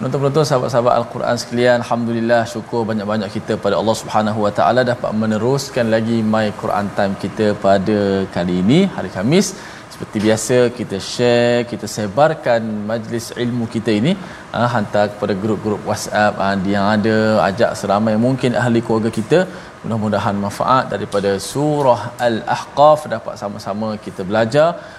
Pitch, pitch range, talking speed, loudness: 110 Hz, 105-120 Hz, 135 wpm, -17 LUFS